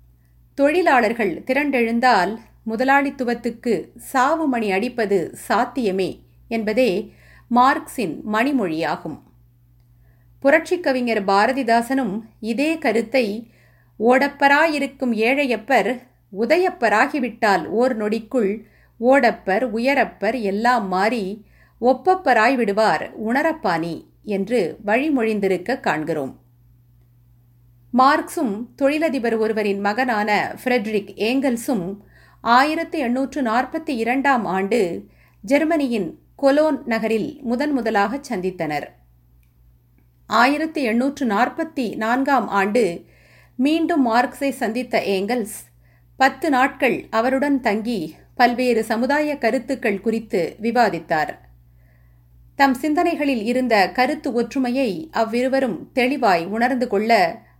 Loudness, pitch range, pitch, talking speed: -20 LUFS, 200-270 Hz, 235 Hz, 70 wpm